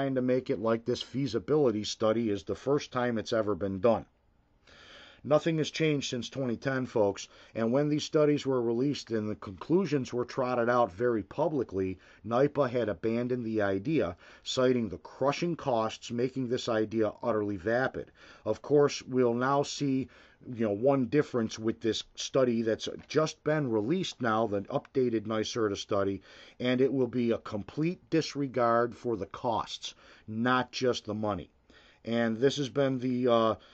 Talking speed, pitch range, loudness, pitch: 155 wpm, 110-135 Hz, -30 LUFS, 120 Hz